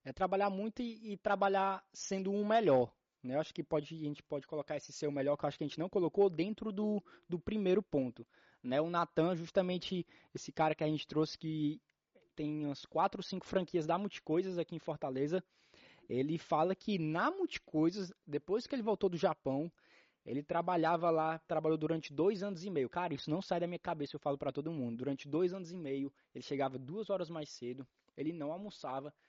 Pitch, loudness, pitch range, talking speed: 165 Hz, -37 LUFS, 150-190 Hz, 215 wpm